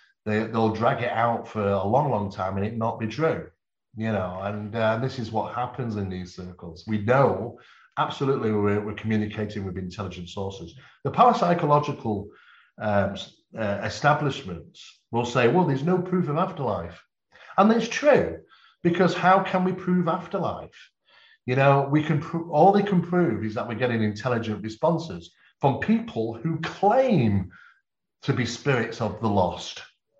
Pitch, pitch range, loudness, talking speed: 115 Hz, 105-160 Hz, -24 LUFS, 165 wpm